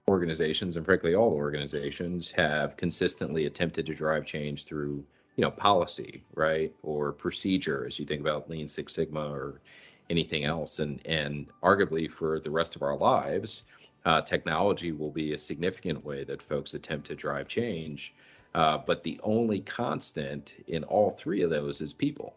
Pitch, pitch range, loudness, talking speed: 75 Hz, 75-80 Hz, -30 LUFS, 165 wpm